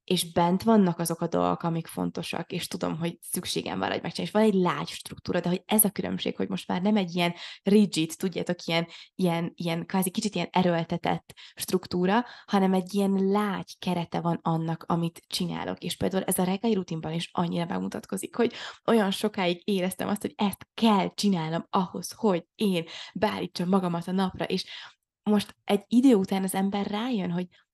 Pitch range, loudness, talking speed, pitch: 170-205 Hz, -27 LUFS, 180 wpm, 185 Hz